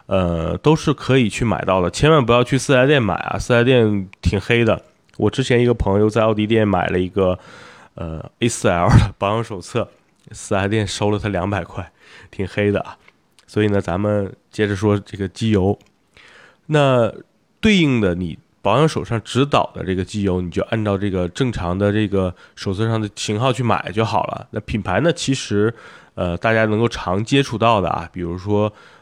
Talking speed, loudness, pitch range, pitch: 275 characters per minute, -19 LUFS, 95-120 Hz, 105 Hz